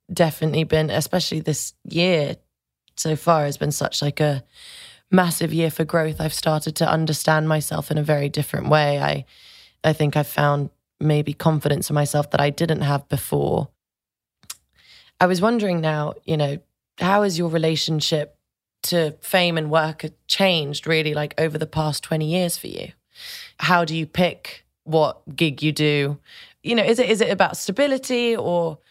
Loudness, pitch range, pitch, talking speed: -21 LUFS, 150-170 Hz, 155 Hz, 170 wpm